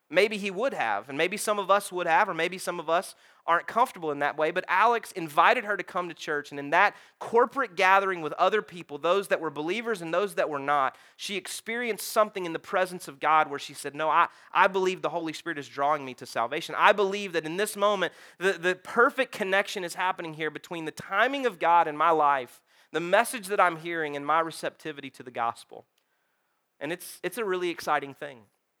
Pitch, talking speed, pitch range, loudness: 175 Hz, 225 wpm, 155-200 Hz, -27 LUFS